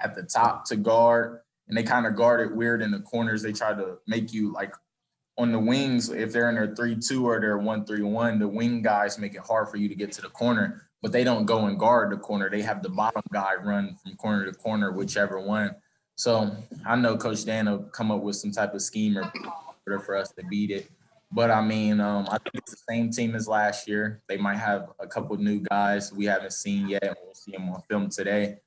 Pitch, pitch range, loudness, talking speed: 105 Hz, 100-115 Hz, -26 LUFS, 245 wpm